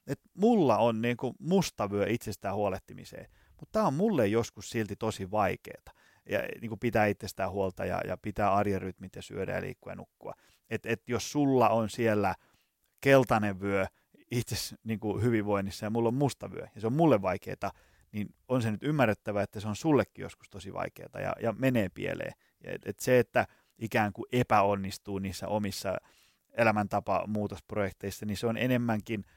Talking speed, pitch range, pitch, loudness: 170 wpm, 100-120 Hz, 110 Hz, -30 LUFS